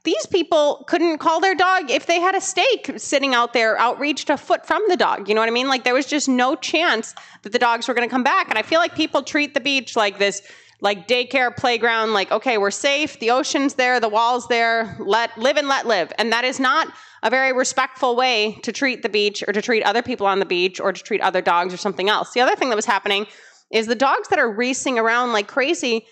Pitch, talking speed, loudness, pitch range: 250 Hz, 255 wpm, -19 LUFS, 225-290 Hz